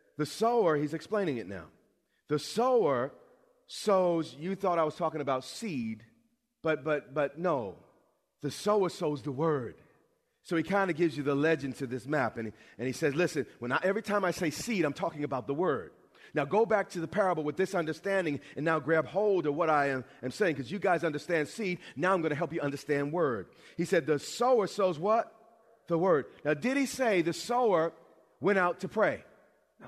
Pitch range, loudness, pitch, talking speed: 150-200 Hz, -31 LUFS, 165 Hz, 210 wpm